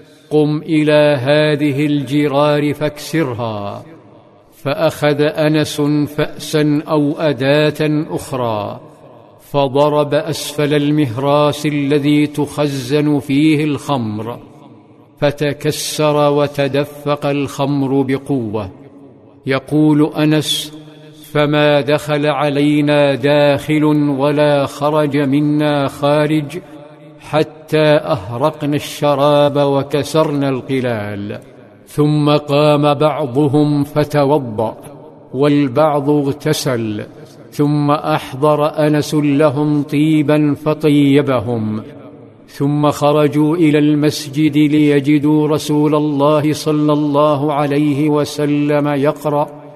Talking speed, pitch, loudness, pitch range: 75 wpm, 150 Hz, -15 LUFS, 145-150 Hz